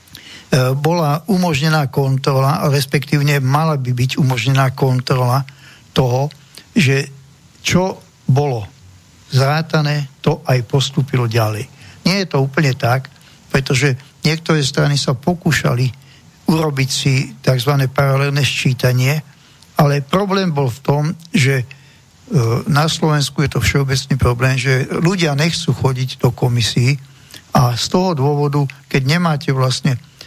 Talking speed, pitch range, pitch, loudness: 115 wpm, 130-150 Hz, 140 Hz, -16 LUFS